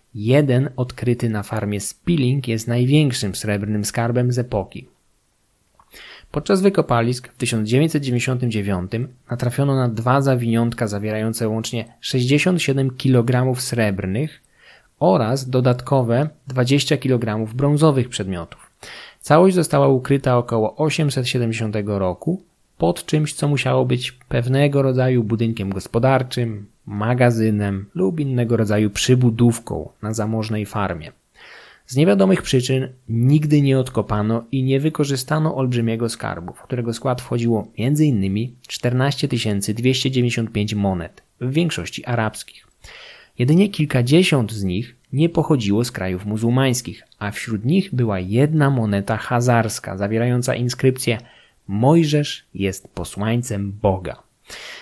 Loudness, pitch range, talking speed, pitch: -19 LUFS, 110-135 Hz, 105 wpm, 125 Hz